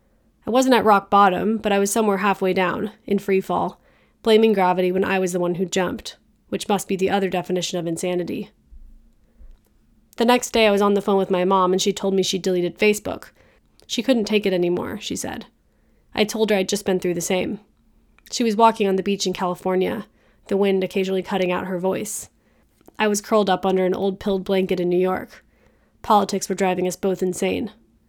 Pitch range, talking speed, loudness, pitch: 185-205 Hz, 210 wpm, -21 LUFS, 195 Hz